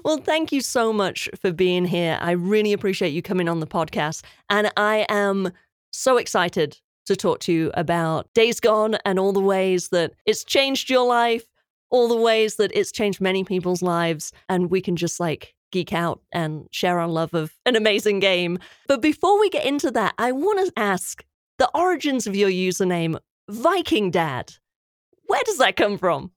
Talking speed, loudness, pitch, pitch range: 190 wpm, -21 LUFS, 200 Hz, 175-235 Hz